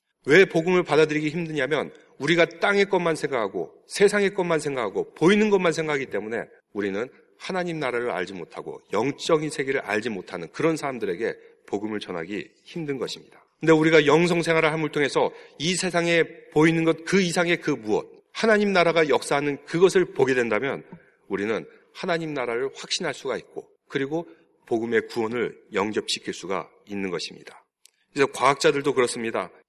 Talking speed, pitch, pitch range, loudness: 380 characters per minute, 170 Hz, 155-220 Hz, -24 LUFS